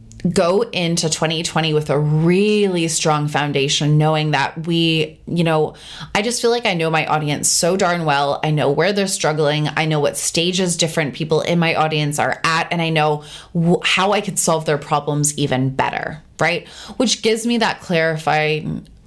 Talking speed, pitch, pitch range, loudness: 185 wpm, 160 Hz, 150-175 Hz, -17 LUFS